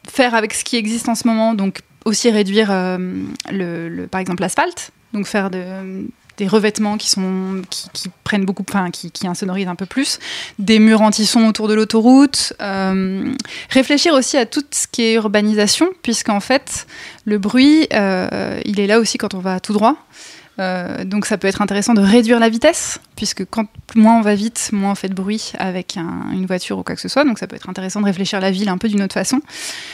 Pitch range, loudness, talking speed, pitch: 190-230 Hz, -16 LUFS, 220 wpm, 210 Hz